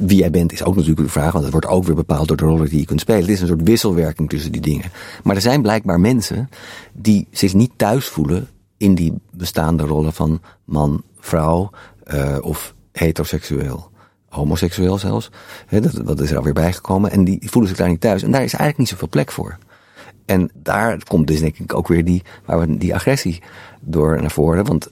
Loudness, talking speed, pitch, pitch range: -17 LUFS, 215 wpm, 85 Hz, 80-100 Hz